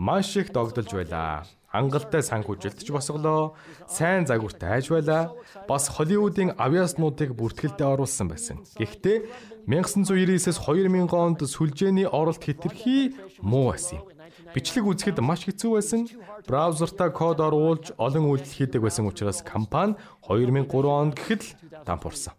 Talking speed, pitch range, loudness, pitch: 125 wpm, 135-190 Hz, -25 LUFS, 160 Hz